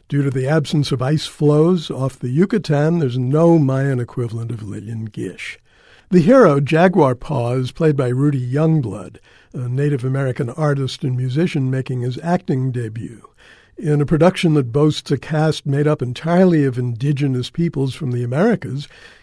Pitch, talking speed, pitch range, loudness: 145 Hz, 160 wpm, 130-155 Hz, -18 LUFS